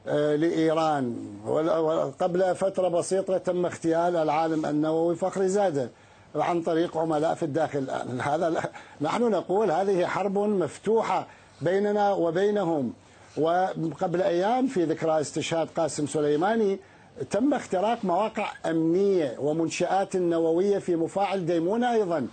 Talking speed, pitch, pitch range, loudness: 105 wpm, 170 Hz, 160-190 Hz, -26 LUFS